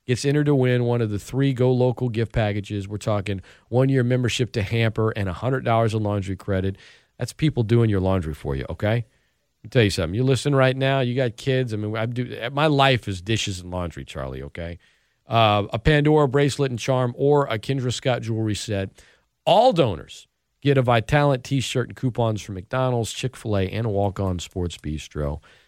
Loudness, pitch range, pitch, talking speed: -22 LUFS, 100-130 Hz, 115 Hz, 205 wpm